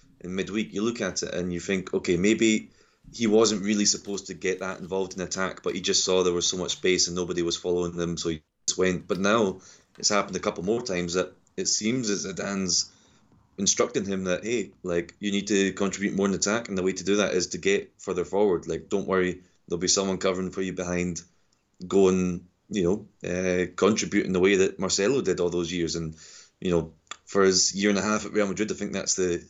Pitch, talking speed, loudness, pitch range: 95 Hz, 235 wpm, -26 LUFS, 90-100 Hz